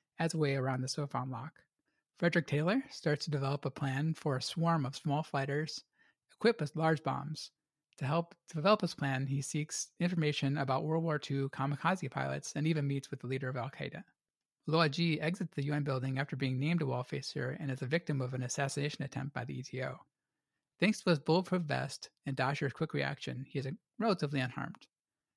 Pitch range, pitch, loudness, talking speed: 135-160 Hz, 145 Hz, -35 LUFS, 195 wpm